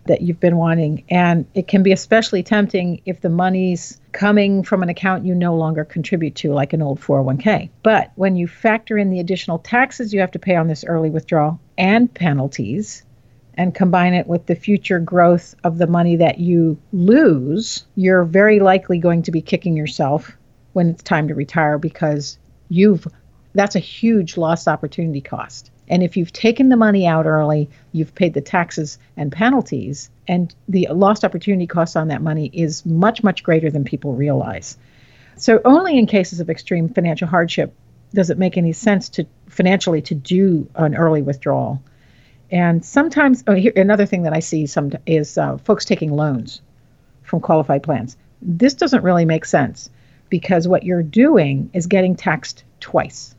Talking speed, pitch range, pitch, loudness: 180 wpm, 155-190 Hz, 175 Hz, -17 LUFS